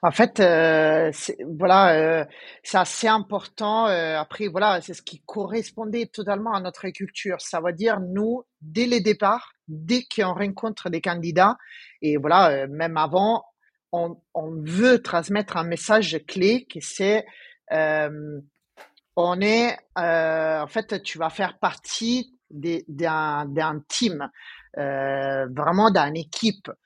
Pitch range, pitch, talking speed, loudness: 160-220 Hz, 180 Hz, 140 wpm, -23 LUFS